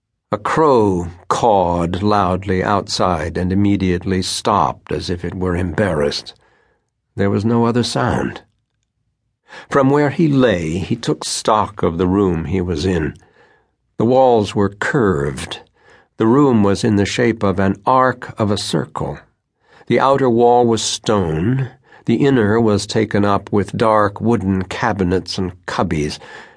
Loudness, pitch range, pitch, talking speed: -17 LUFS, 95-115 Hz, 105 Hz, 140 wpm